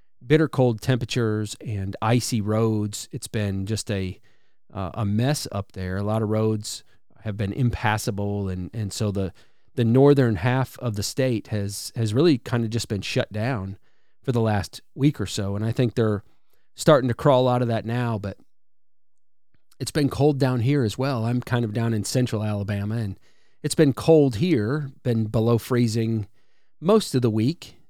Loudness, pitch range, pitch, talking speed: -24 LUFS, 105-130 Hz, 115 Hz, 185 wpm